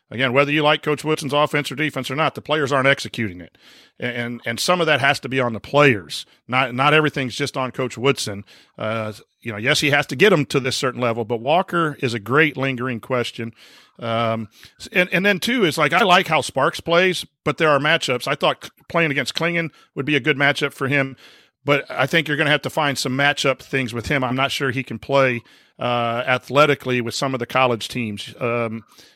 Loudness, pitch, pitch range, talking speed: -19 LUFS, 135 Hz, 120-150 Hz, 230 wpm